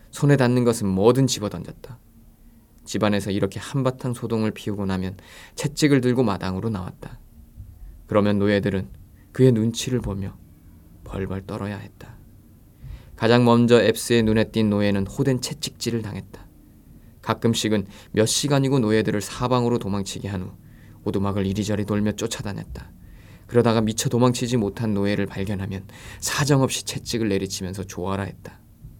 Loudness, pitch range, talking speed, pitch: -22 LUFS, 100-120 Hz, 330 characters per minute, 105 Hz